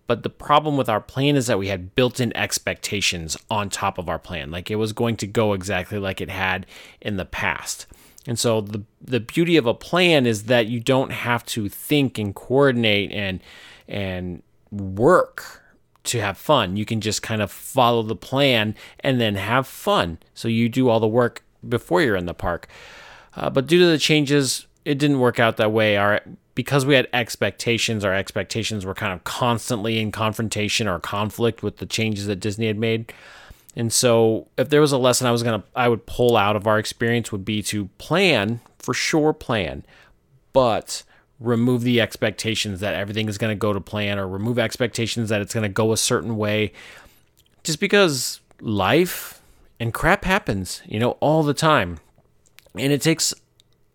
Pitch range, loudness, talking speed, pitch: 105-125 Hz, -21 LUFS, 190 wpm, 115 Hz